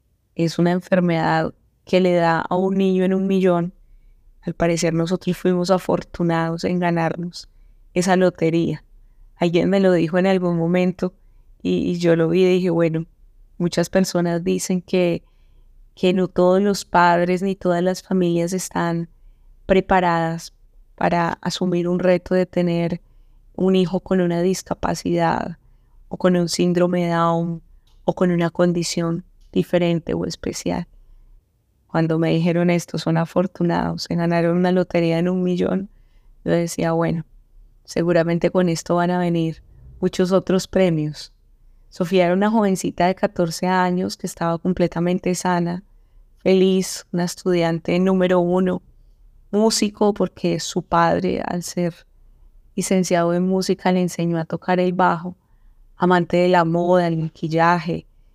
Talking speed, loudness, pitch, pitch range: 140 wpm, -20 LUFS, 175 Hz, 165-185 Hz